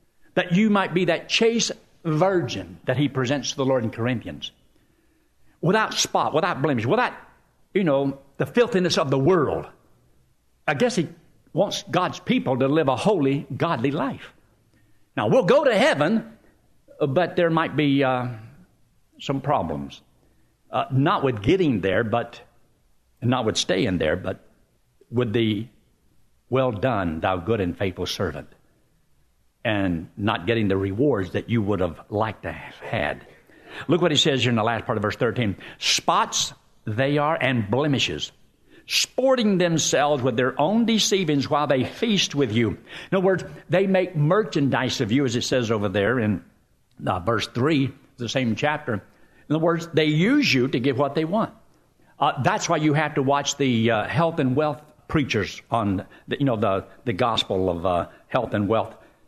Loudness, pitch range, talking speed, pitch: -23 LUFS, 115-160 Hz, 170 wpm, 135 Hz